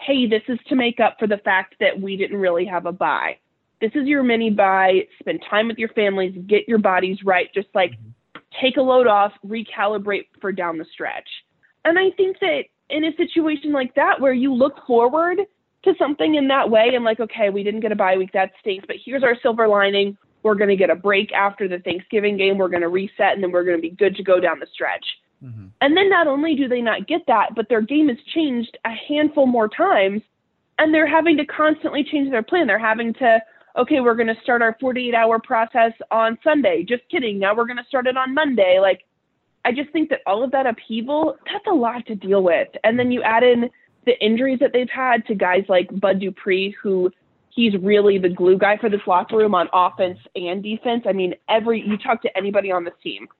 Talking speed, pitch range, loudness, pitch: 230 wpm, 195-270 Hz, -19 LUFS, 225 Hz